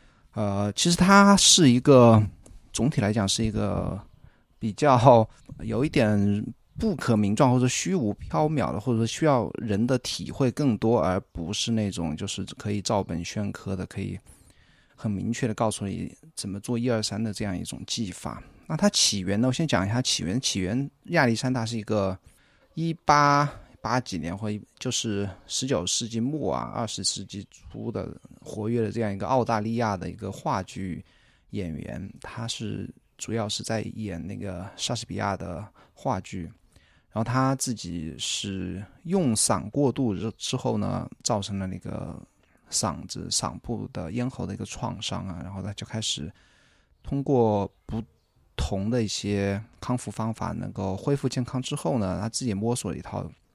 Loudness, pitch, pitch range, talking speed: -26 LUFS, 110 Hz, 100-125 Hz, 245 characters per minute